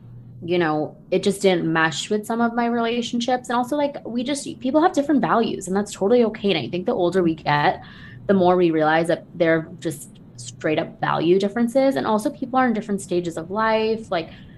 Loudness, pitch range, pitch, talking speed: -21 LUFS, 165-240 Hz, 195 Hz, 215 wpm